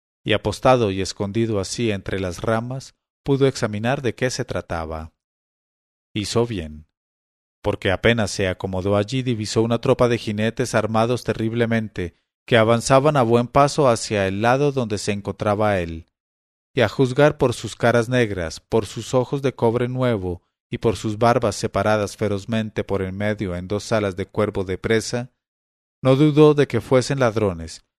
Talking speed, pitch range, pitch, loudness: 160 wpm, 95-120 Hz, 110 Hz, -21 LUFS